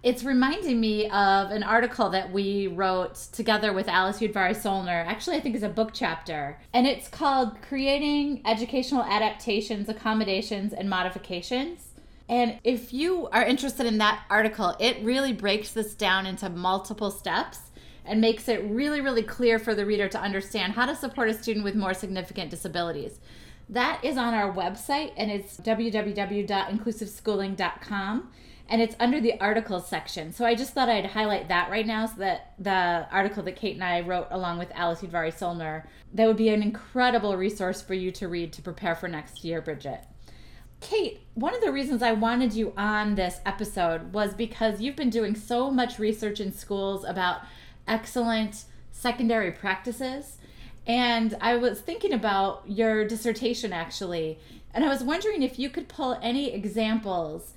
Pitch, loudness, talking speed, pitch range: 215 Hz, -27 LUFS, 170 wpm, 190-240 Hz